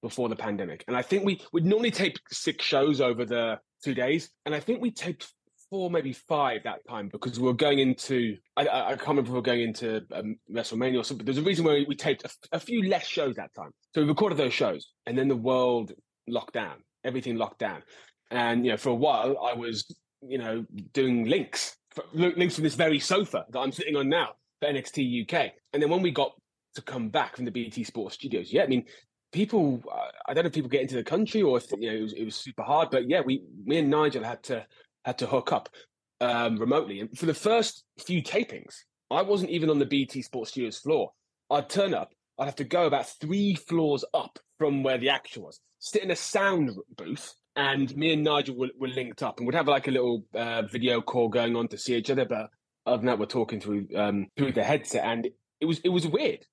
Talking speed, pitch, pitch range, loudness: 240 wpm, 135 Hz, 120-165 Hz, -28 LUFS